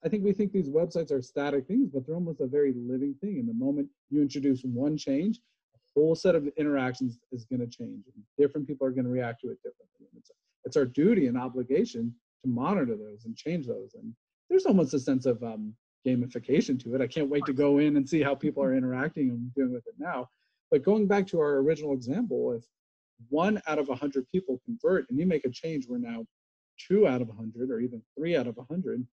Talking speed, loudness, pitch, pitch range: 230 wpm, -29 LUFS, 145 Hz, 125-185 Hz